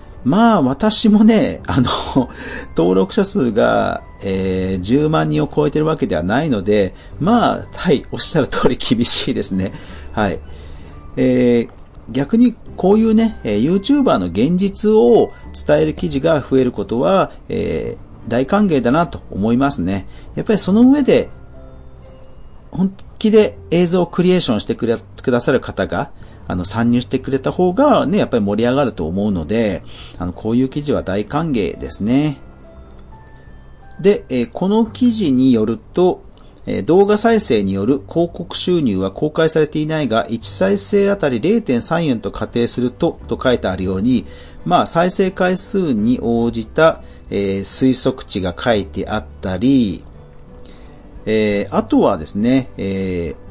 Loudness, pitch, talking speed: -16 LUFS, 125 Hz, 285 characters per minute